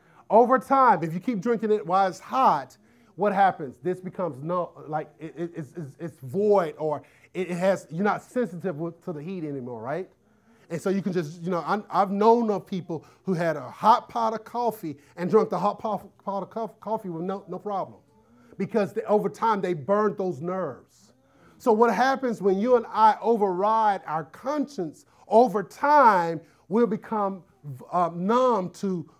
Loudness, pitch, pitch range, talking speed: -25 LUFS, 195 Hz, 170-220 Hz, 180 wpm